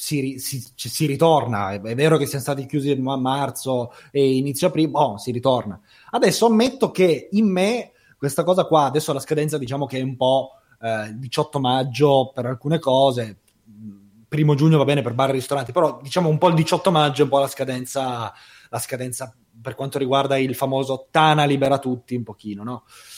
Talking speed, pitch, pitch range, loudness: 190 wpm, 135 Hz, 125-150 Hz, -20 LUFS